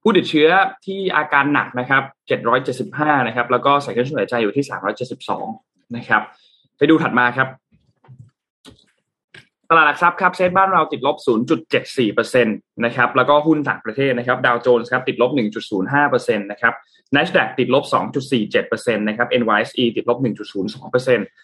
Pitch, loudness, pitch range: 140 Hz, -18 LUFS, 125-180 Hz